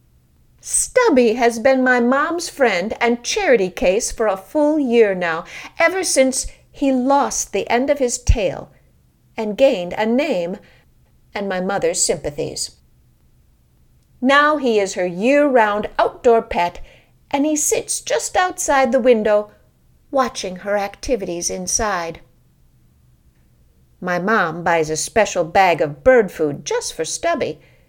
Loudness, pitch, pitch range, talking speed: -18 LUFS, 235 Hz, 190-280 Hz, 135 wpm